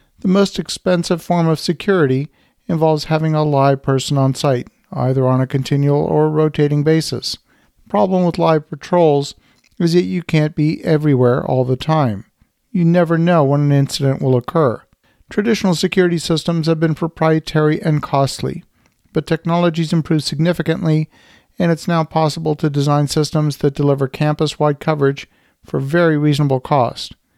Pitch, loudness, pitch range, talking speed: 155 Hz, -16 LUFS, 140-165 Hz, 150 wpm